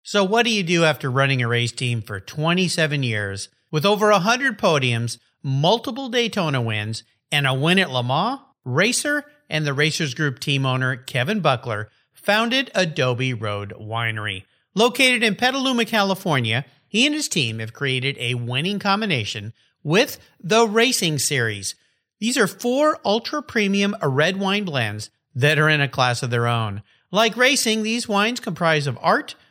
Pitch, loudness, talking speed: 155 Hz, -20 LUFS, 160 wpm